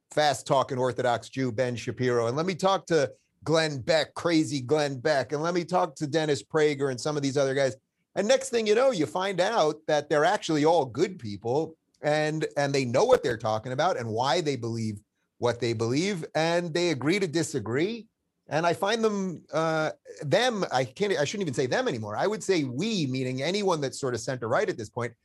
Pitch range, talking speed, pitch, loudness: 130-175 Hz, 215 wpm, 150 Hz, -27 LUFS